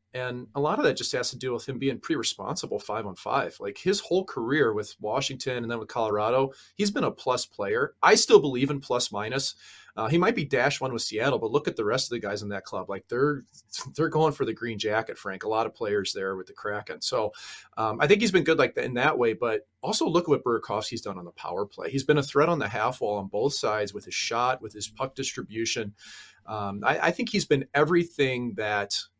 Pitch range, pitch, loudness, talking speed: 110-150 Hz, 125 Hz, -27 LUFS, 255 wpm